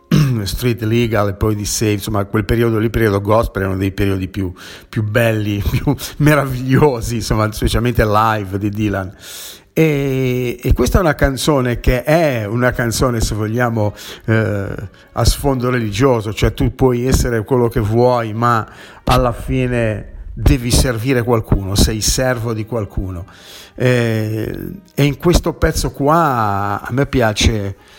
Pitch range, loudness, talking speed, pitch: 105-125 Hz, -16 LUFS, 145 wpm, 115 Hz